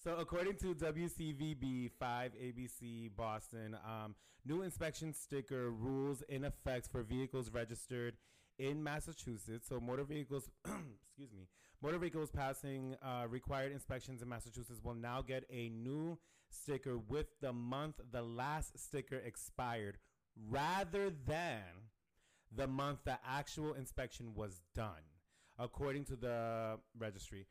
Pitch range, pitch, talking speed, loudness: 115-140 Hz, 130 Hz, 125 wpm, -45 LUFS